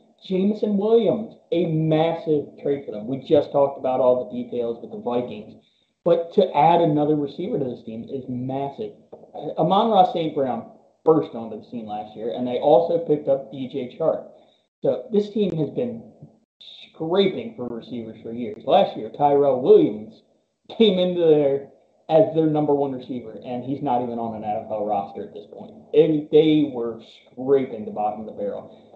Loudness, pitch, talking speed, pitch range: -22 LUFS, 145 Hz, 180 wpm, 125-170 Hz